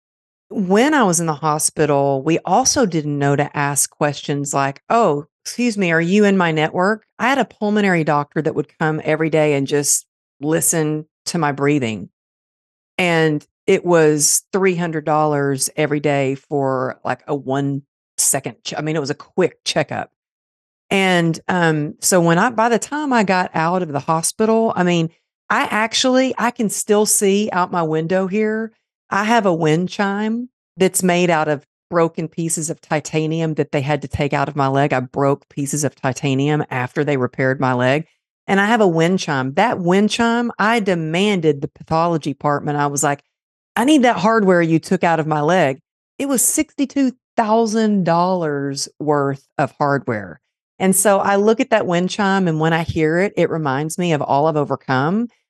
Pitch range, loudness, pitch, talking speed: 145-200 Hz, -18 LUFS, 165 Hz, 185 wpm